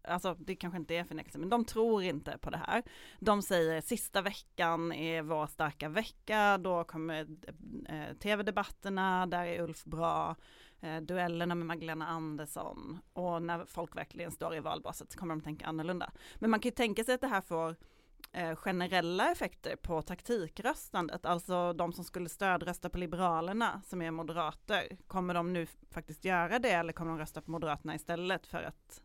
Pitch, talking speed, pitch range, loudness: 175 Hz, 170 wpm, 165-190 Hz, -36 LUFS